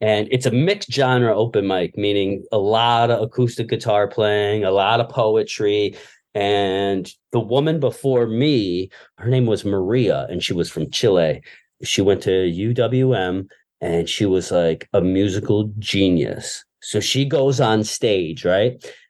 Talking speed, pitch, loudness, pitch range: 155 wpm, 110 Hz, -19 LUFS, 100-130 Hz